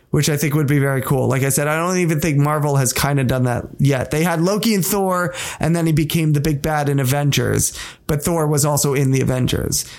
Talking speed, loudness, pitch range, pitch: 250 wpm, -18 LUFS, 140-165 Hz, 150 Hz